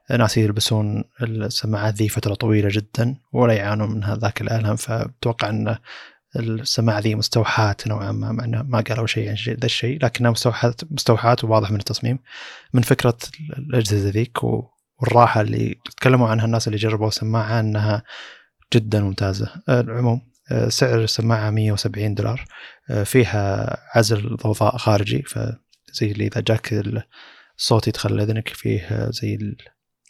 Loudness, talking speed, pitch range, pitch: -21 LUFS, 130 wpm, 105-120 Hz, 115 Hz